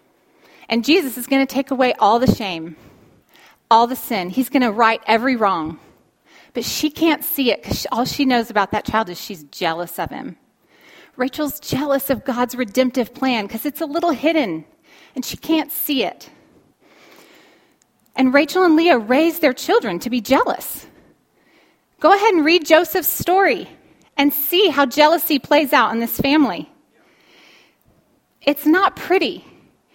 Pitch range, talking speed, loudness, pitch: 240-315 Hz, 160 wpm, -18 LUFS, 275 Hz